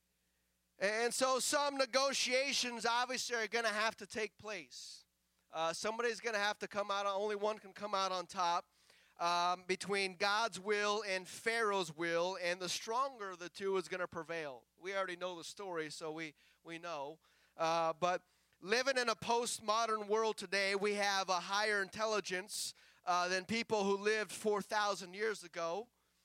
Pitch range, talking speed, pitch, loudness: 175-220 Hz, 170 wpm, 200 Hz, -37 LUFS